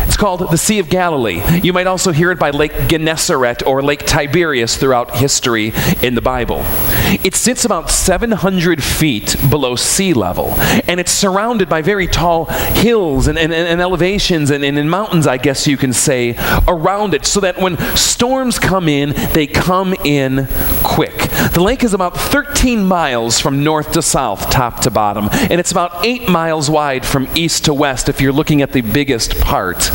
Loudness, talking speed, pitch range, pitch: -13 LUFS, 185 wpm, 135-185 Hz, 160 Hz